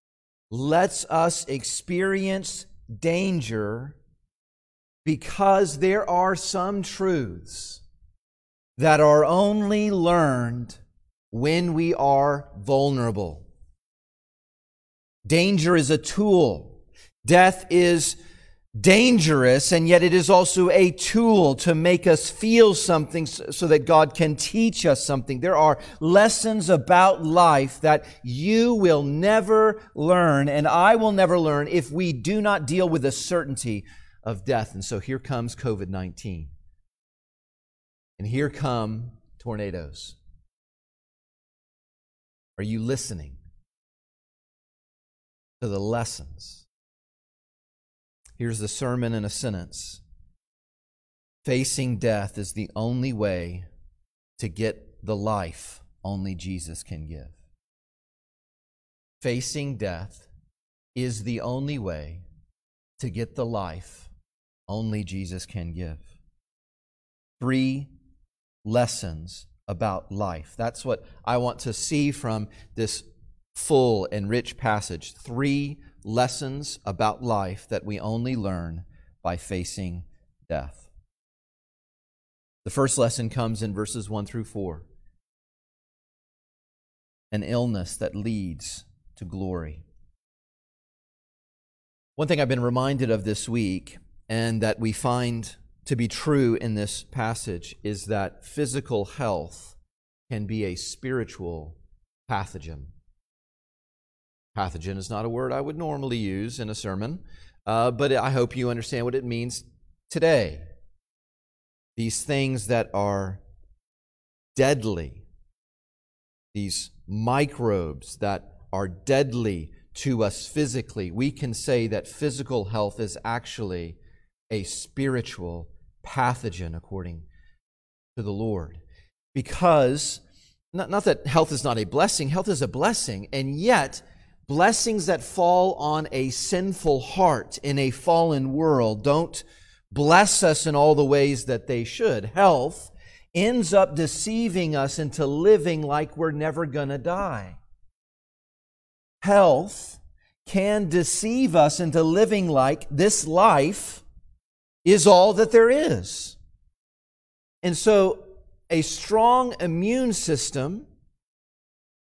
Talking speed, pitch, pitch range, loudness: 115 wpm, 120 Hz, 95-155 Hz, -23 LUFS